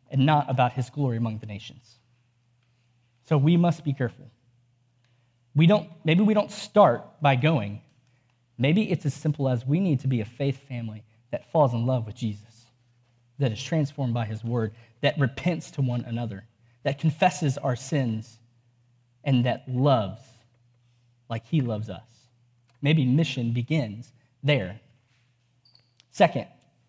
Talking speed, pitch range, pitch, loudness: 145 wpm, 120-140 Hz, 125 Hz, -25 LUFS